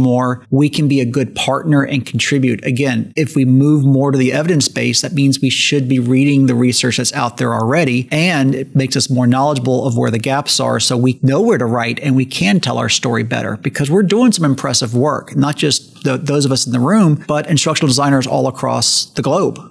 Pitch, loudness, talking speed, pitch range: 135 Hz, -14 LUFS, 230 wpm, 125-145 Hz